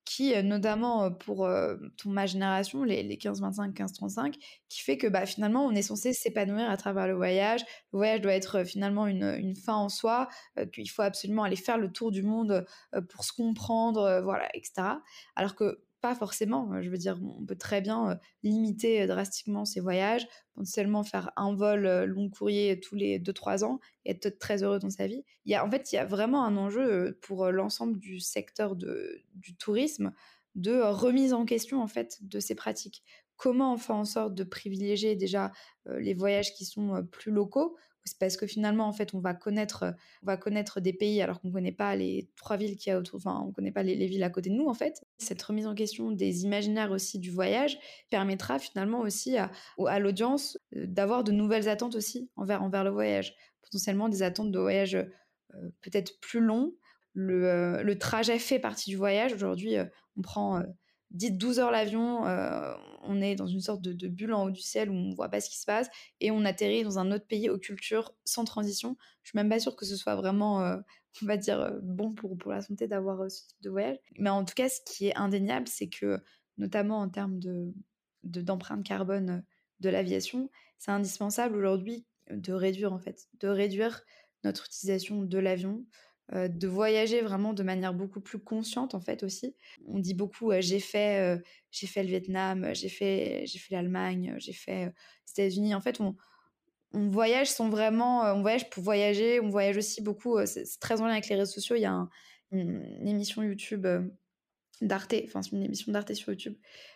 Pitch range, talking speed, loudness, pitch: 190-220 Hz, 210 wpm, -31 LUFS, 200 Hz